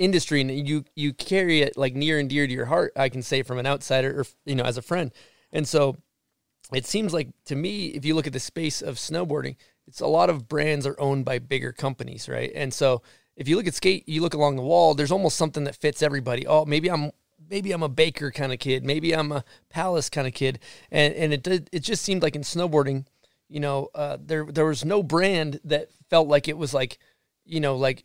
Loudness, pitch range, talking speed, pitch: -25 LUFS, 135-160 Hz, 240 wpm, 150 Hz